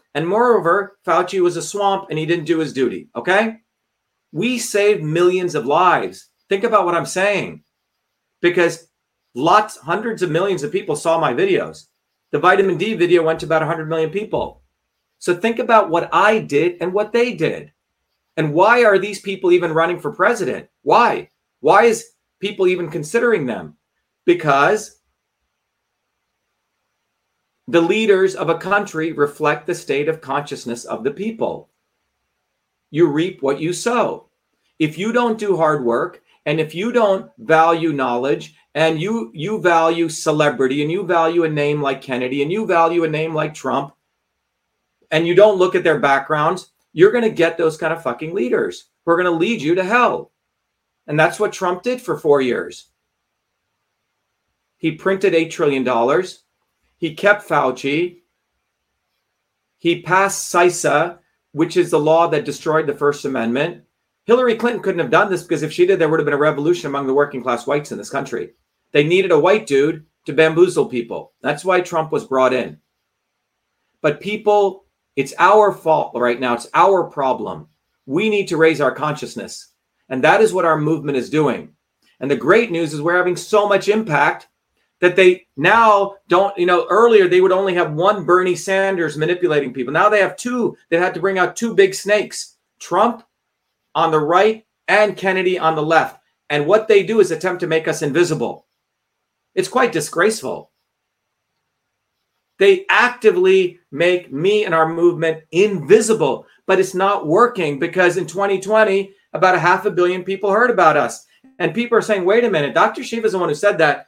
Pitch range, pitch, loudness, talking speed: 160-205 Hz, 175 Hz, -17 LUFS, 175 wpm